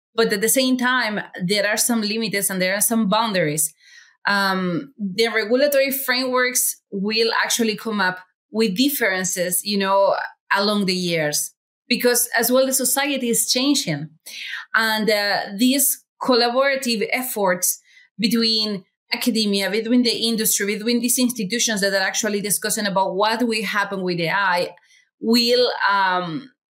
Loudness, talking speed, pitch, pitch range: -19 LUFS, 135 wpm, 220 Hz, 200-245 Hz